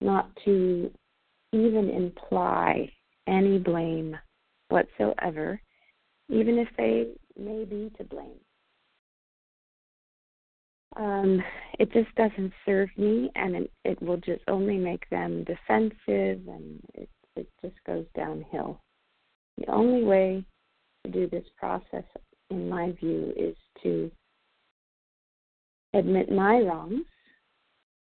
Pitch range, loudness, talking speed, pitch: 155-215 Hz, -28 LUFS, 105 wpm, 190 Hz